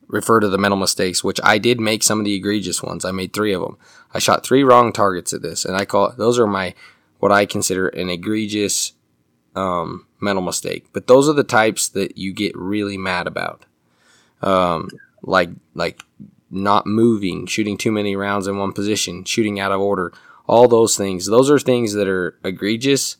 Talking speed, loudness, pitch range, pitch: 200 wpm, -18 LUFS, 95-110 Hz, 100 Hz